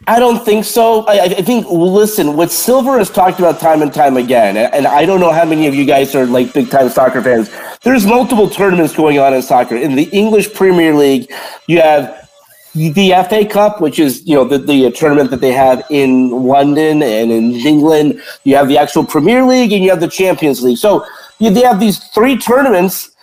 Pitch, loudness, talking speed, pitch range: 165 Hz, -10 LUFS, 215 wpm, 140-210 Hz